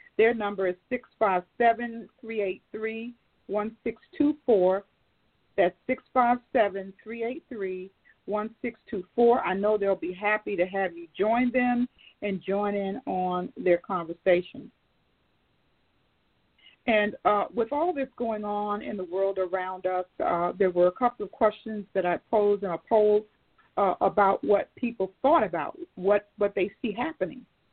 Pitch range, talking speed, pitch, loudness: 190-230 Hz, 135 wpm, 205 Hz, -27 LUFS